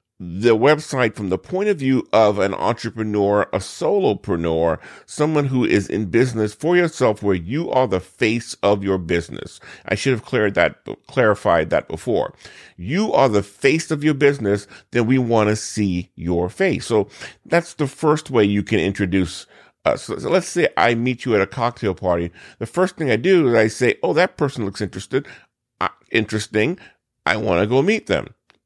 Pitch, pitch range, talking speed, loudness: 110 Hz, 100-135 Hz, 185 wpm, -19 LUFS